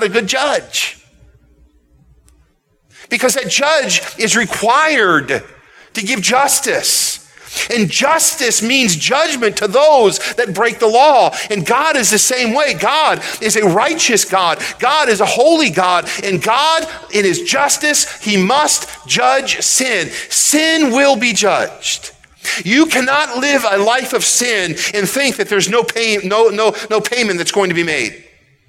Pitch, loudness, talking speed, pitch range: 230 Hz, -13 LUFS, 150 wpm, 200-280 Hz